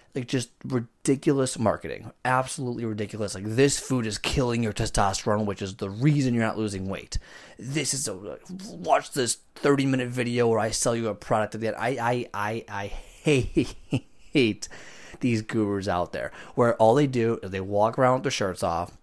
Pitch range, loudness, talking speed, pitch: 105-130 Hz, -26 LUFS, 190 wpm, 115 Hz